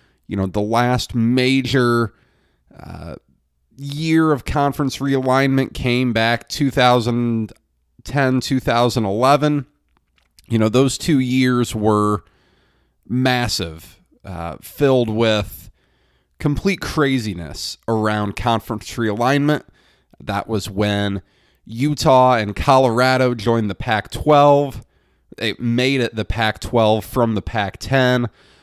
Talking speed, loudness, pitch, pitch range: 105 wpm, -18 LUFS, 120 Hz, 105-130 Hz